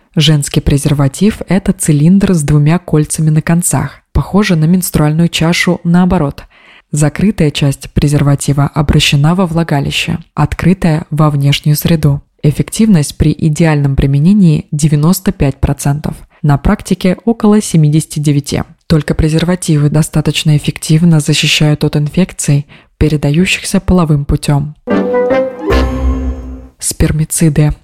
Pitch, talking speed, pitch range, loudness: 155 Hz, 95 wpm, 145-175 Hz, -11 LUFS